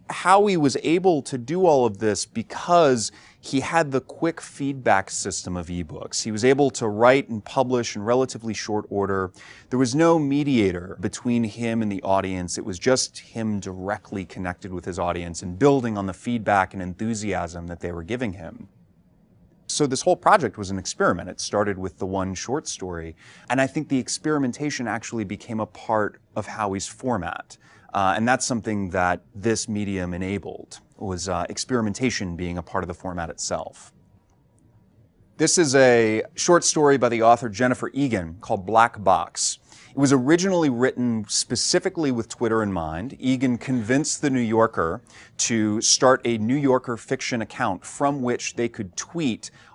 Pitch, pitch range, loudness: 115 Hz, 95-130 Hz, -23 LUFS